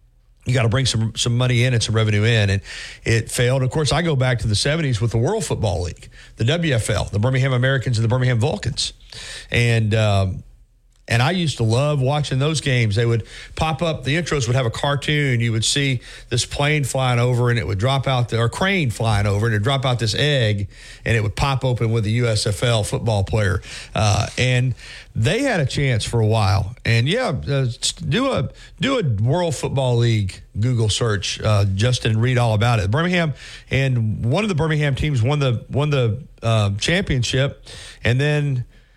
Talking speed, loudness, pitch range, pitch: 205 wpm, -20 LUFS, 110-135 Hz, 120 Hz